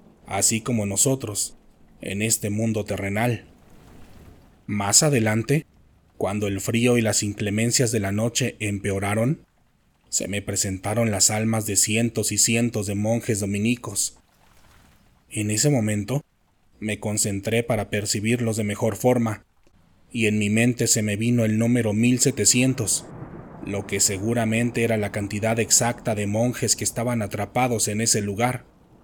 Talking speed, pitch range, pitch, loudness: 135 wpm, 105-115 Hz, 110 Hz, -22 LUFS